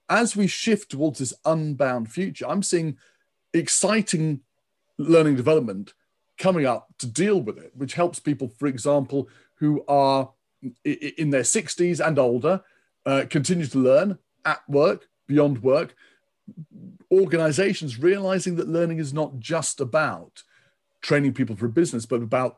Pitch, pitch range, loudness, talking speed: 155 Hz, 135-185 Hz, -23 LUFS, 140 wpm